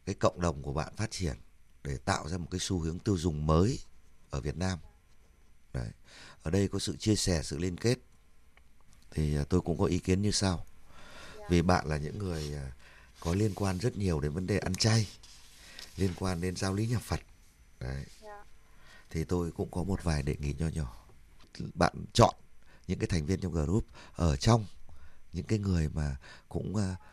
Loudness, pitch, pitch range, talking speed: -32 LUFS, 85 Hz, 75-95 Hz, 190 wpm